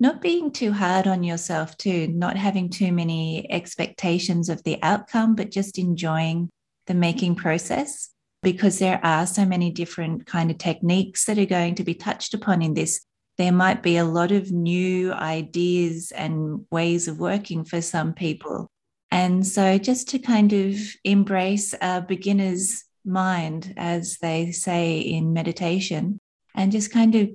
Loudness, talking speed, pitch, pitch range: -23 LUFS, 160 wpm, 180 Hz, 170-195 Hz